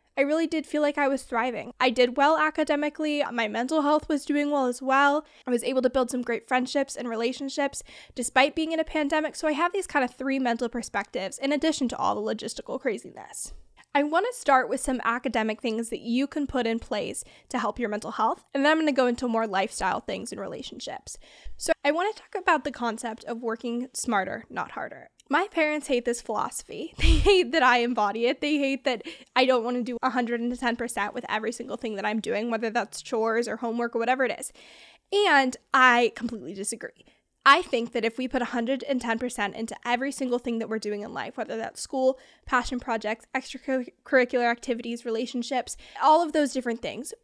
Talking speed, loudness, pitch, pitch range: 205 wpm, -26 LUFS, 255 Hz, 235-285 Hz